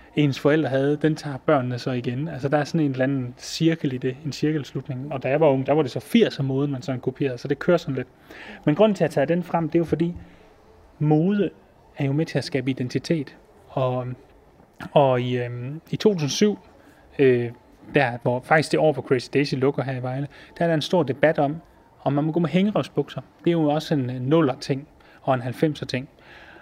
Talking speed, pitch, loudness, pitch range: 230 wpm, 140 Hz, -23 LUFS, 130-155 Hz